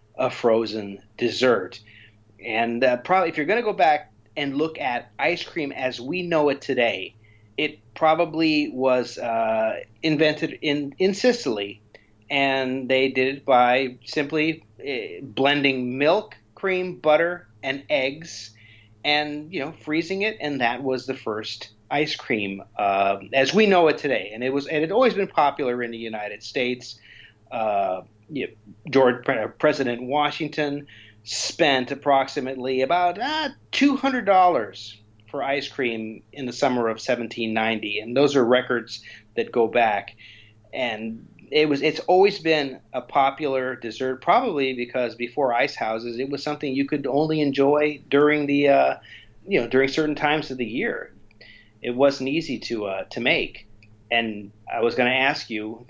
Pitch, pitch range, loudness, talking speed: 130 Hz, 115-150 Hz, -23 LUFS, 160 wpm